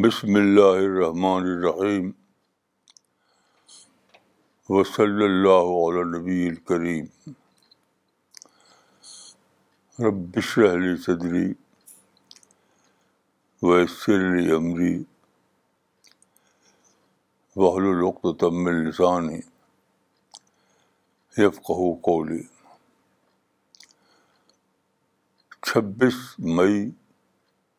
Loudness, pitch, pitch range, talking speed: -22 LUFS, 90 Hz, 85-95 Hz, 50 wpm